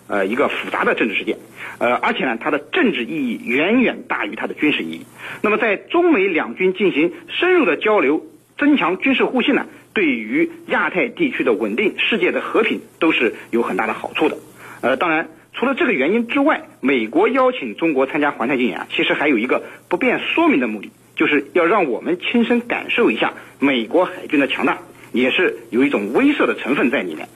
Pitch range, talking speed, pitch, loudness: 240-335 Hz, 315 characters per minute, 290 Hz, -18 LUFS